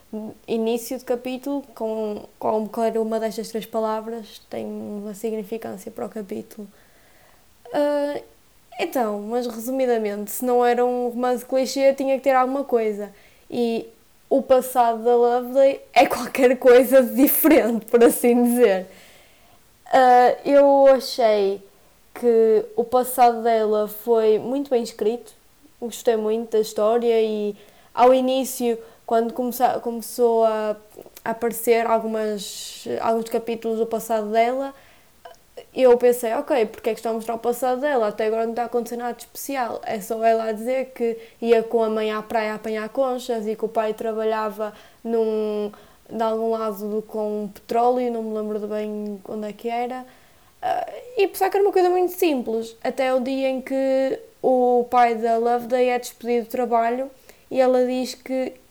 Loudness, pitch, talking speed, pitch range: -21 LUFS, 235 Hz, 155 wpm, 220-255 Hz